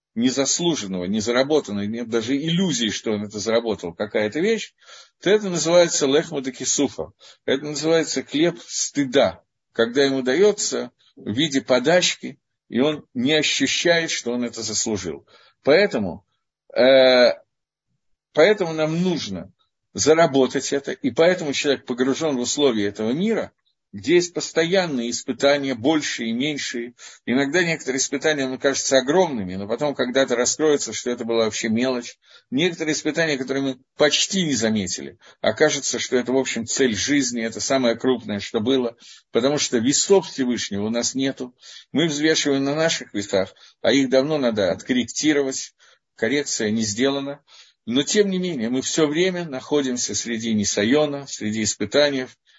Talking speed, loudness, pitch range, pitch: 140 wpm, -21 LUFS, 120-155 Hz, 135 Hz